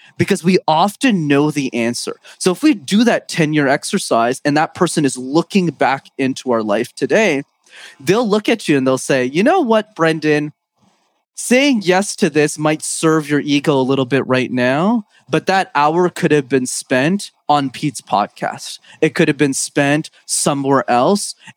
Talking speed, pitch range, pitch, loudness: 180 wpm, 140-185 Hz, 155 Hz, -16 LUFS